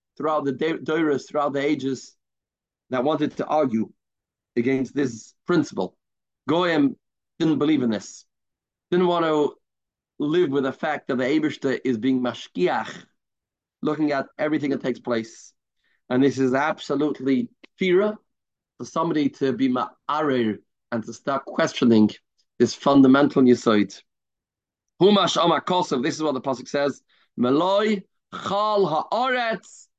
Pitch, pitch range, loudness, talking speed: 140 Hz, 130-160 Hz, -23 LUFS, 130 wpm